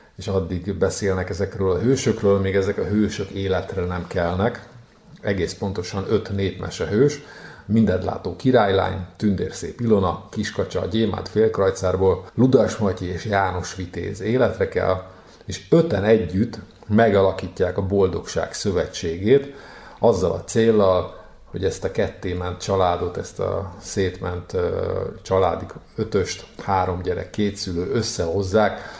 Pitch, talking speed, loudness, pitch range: 95 Hz, 120 wpm, -22 LUFS, 95-105 Hz